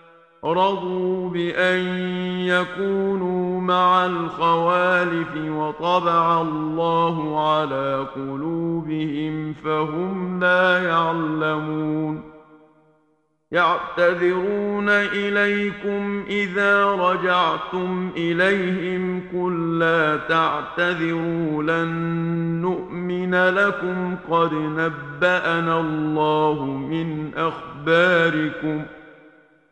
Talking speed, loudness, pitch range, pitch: 55 wpm, -21 LUFS, 155-180 Hz, 165 Hz